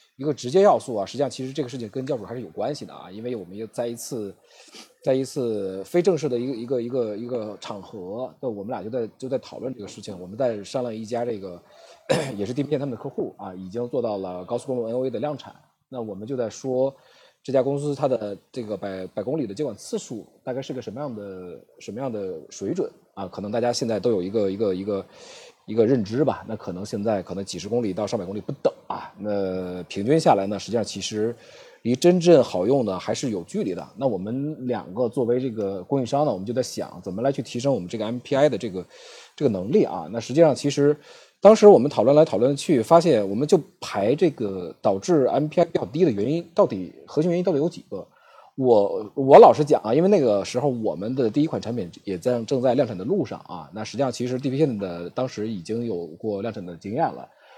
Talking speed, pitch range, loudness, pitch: 350 characters per minute, 105-145 Hz, -23 LUFS, 125 Hz